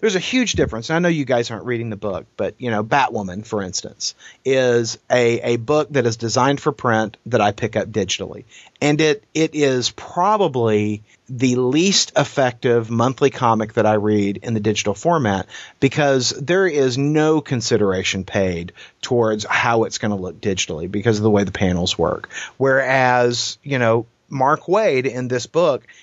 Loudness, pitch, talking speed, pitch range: -19 LUFS, 120 Hz, 180 wpm, 110-135 Hz